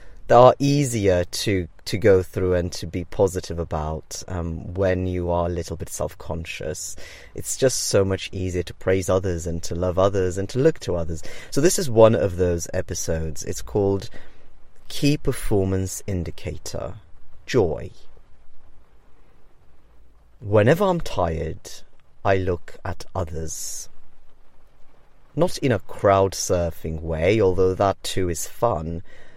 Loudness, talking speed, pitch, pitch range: -23 LUFS, 140 wpm, 90 Hz, 85-100 Hz